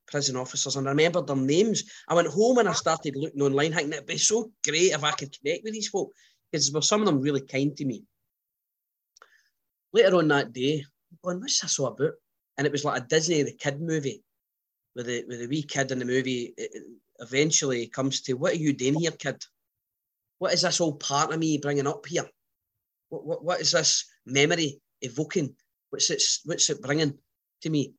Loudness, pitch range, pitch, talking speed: -26 LUFS, 135-170 Hz, 145 Hz, 210 wpm